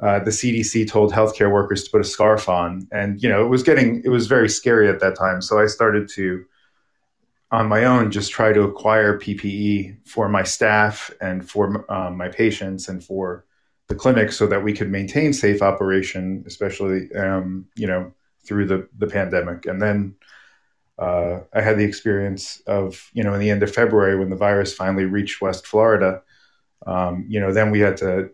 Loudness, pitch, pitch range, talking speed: -19 LUFS, 100 Hz, 95-105 Hz, 195 wpm